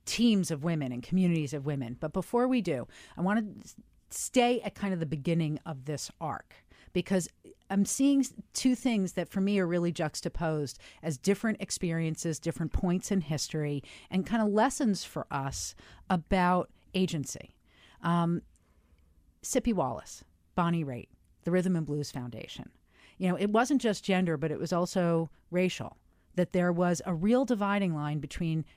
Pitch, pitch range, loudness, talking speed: 175 Hz, 150-195 Hz, -31 LUFS, 165 wpm